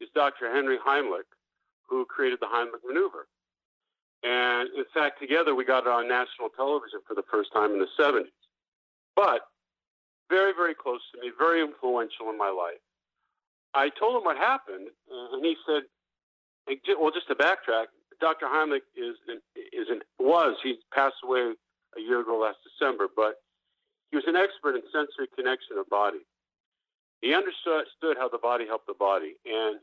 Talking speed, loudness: 165 wpm, -27 LUFS